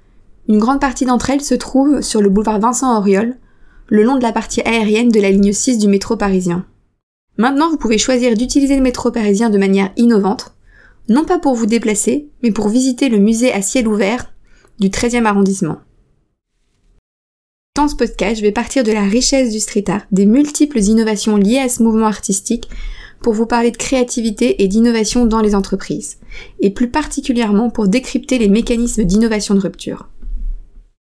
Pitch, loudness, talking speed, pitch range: 225 Hz, -14 LUFS, 175 wpm, 205-250 Hz